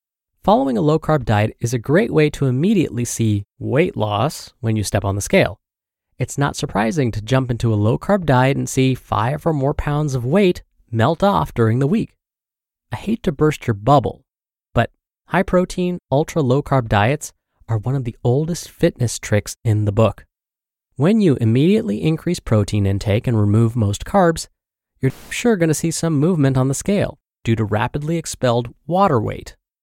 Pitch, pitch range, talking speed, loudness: 130 Hz, 110-160 Hz, 185 wpm, -19 LUFS